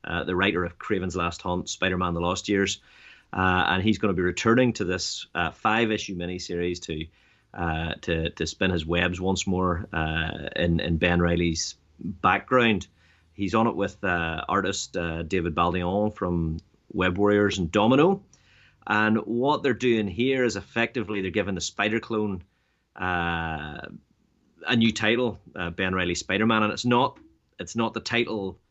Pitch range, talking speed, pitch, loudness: 85-105 Hz, 165 wpm, 95 Hz, -25 LUFS